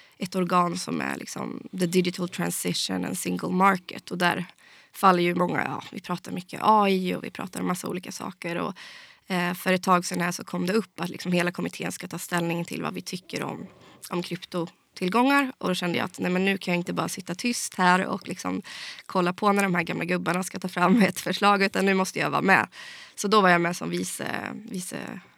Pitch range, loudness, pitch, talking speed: 175-195 Hz, -26 LUFS, 185 Hz, 225 wpm